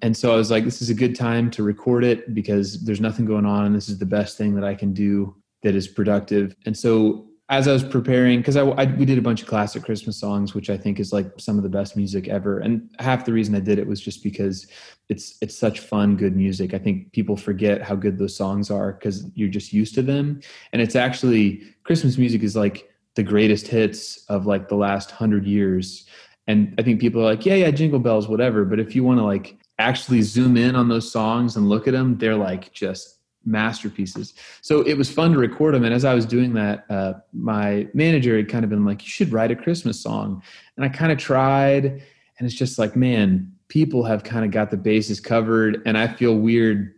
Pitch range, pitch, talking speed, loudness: 100-125 Hz, 110 Hz, 240 wpm, -21 LUFS